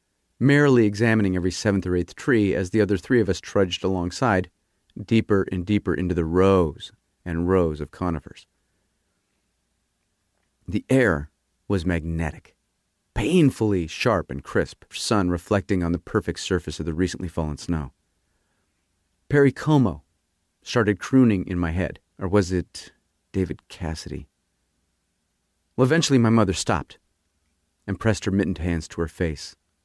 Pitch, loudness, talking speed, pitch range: 90 Hz, -23 LUFS, 140 wpm, 85-105 Hz